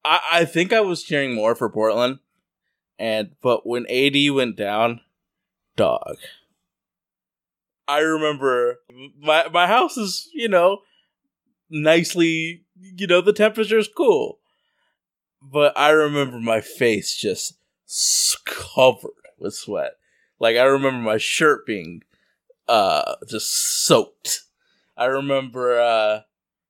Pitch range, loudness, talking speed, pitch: 125-205 Hz, -20 LUFS, 115 wpm, 150 Hz